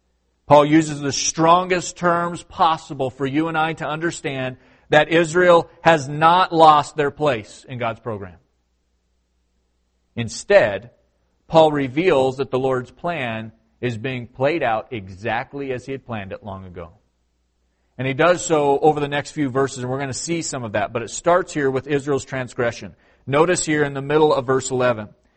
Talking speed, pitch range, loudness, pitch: 175 wpm, 110-155 Hz, -19 LUFS, 135 Hz